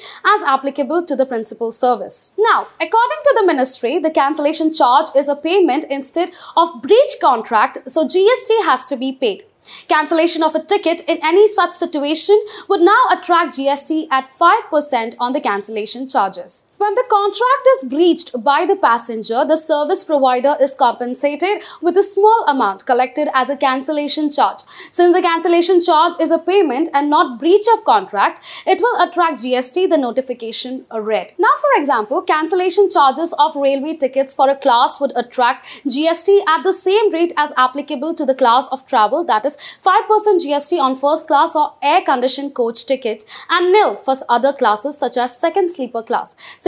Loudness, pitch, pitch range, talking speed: -15 LUFS, 300 Hz, 265-360 Hz, 170 wpm